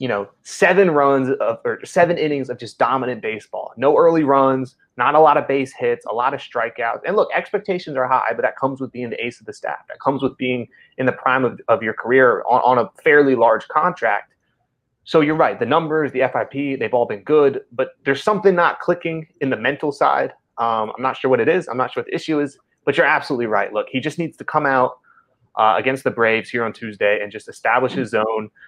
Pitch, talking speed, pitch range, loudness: 135 Hz, 240 wpm, 120-155 Hz, -19 LUFS